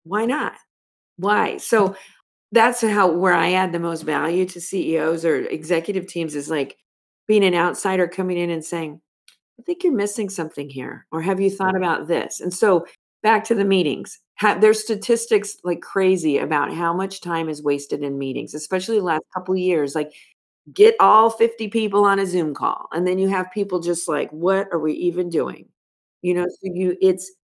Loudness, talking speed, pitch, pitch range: -20 LUFS, 195 wpm, 185 Hz, 170-205 Hz